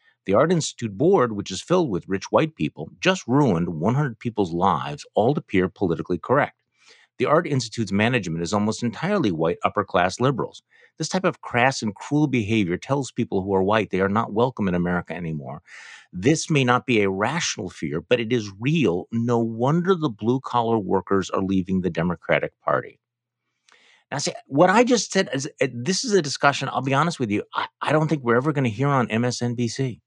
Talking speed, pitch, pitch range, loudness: 195 wpm, 120 Hz, 100-140 Hz, -23 LUFS